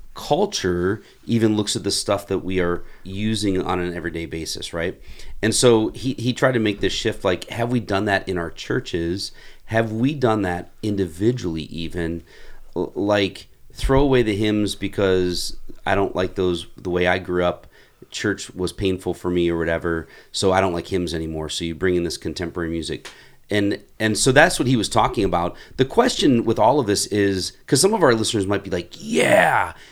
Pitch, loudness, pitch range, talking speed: 95 Hz, -21 LUFS, 85-105 Hz, 200 wpm